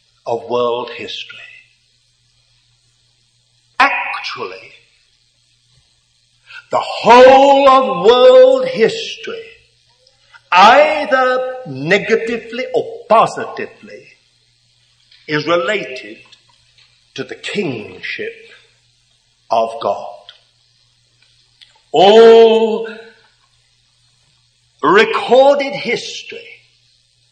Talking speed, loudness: 50 wpm, -12 LUFS